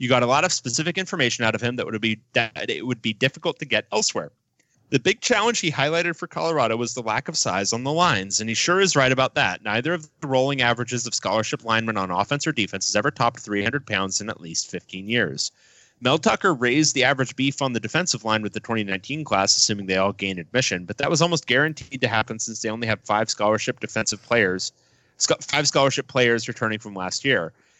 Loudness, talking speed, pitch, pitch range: -22 LUFS, 230 wpm, 120 Hz, 110-140 Hz